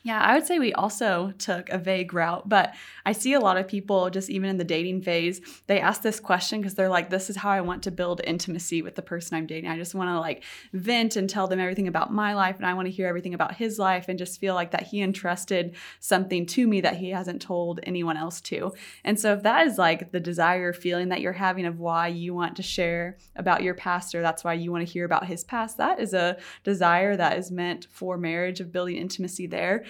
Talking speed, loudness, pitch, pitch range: 255 wpm, -26 LUFS, 180 Hz, 175-195 Hz